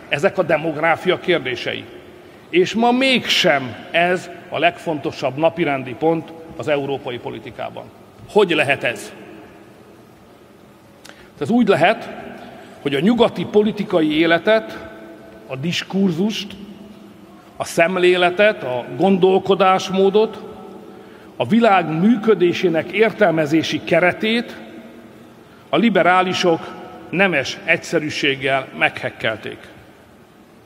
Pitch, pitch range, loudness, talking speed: 175 Hz, 155-195 Hz, -17 LUFS, 80 wpm